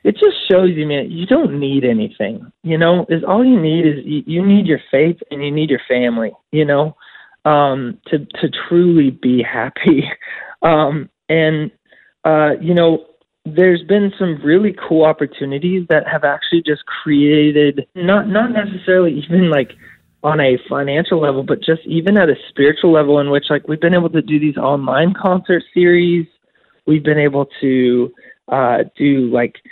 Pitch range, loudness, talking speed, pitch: 145-175 Hz, -15 LUFS, 175 wpm, 155 Hz